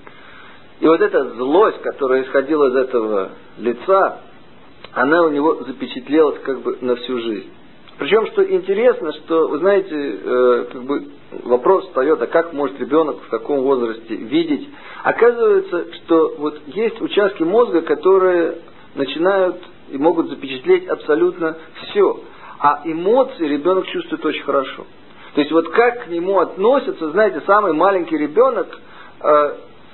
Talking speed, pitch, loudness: 130 wpm, 185 Hz, -17 LUFS